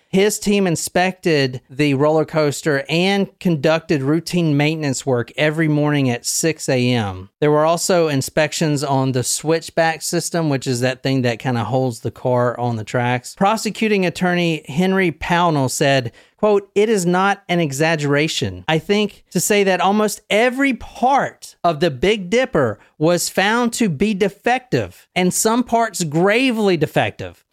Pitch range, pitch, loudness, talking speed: 140-195 Hz, 165 Hz, -18 LUFS, 150 wpm